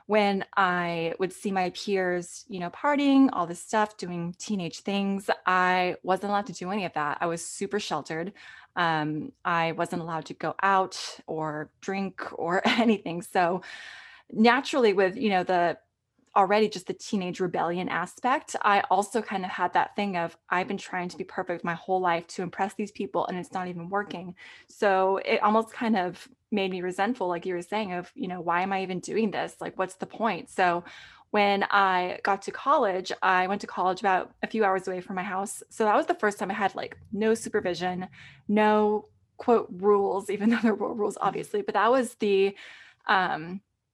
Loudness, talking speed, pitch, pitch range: -27 LUFS, 195 wpm, 190 Hz, 180-210 Hz